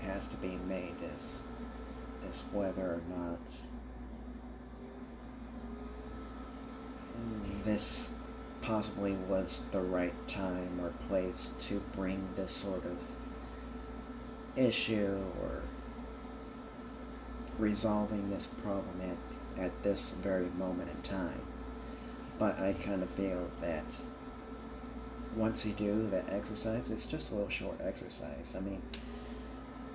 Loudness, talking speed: -39 LUFS, 110 wpm